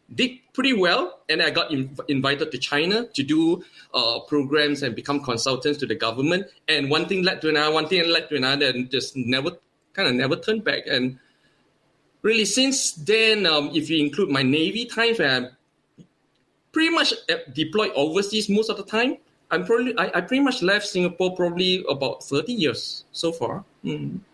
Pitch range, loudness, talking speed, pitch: 145-220 Hz, -22 LUFS, 180 wpm, 175 Hz